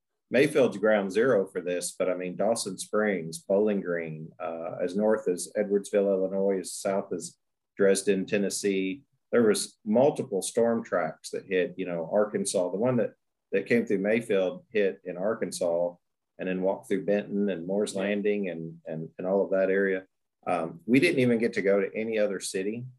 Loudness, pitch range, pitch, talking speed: -27 LUFS, 90-105 Hz, 100 Hz, 180 wpm